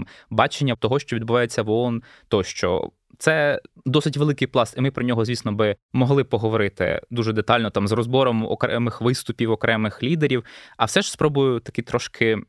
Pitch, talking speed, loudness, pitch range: 120 Hz, 165 wpm, -22 LUFS, 115-135 Hz